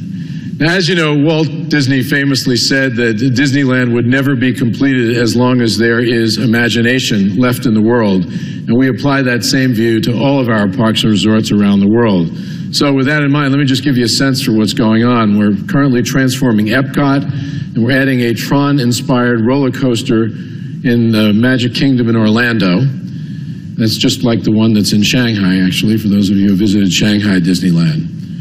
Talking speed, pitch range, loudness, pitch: 190 wpm, 110-140 Hz, -12 LUFS, 125 Hz